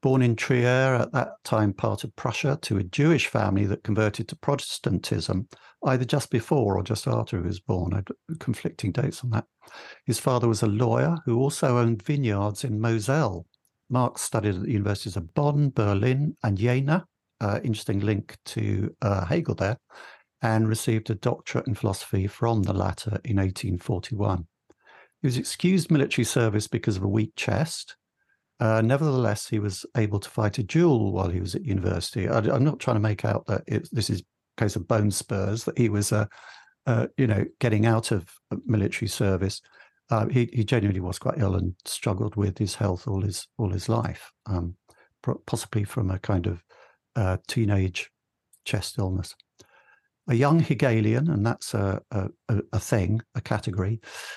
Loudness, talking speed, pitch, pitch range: -26 LUFS, 180 wpm, 110 Hz, 100-125 Hz